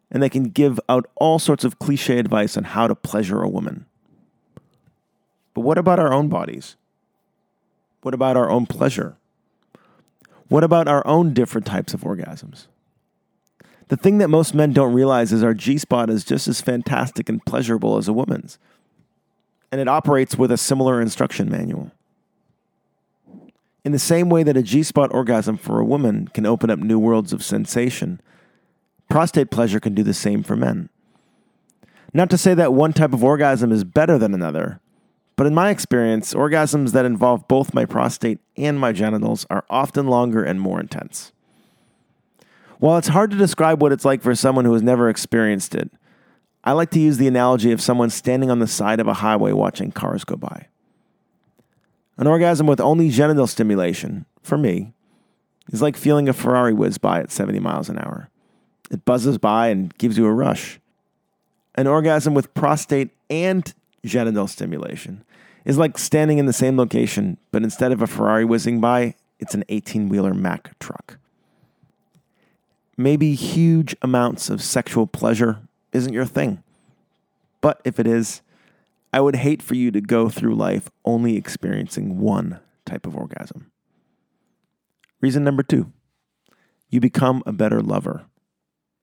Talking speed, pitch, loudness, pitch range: 165 wpm, 130 Hz, -19 LUFS, 115-150 Hz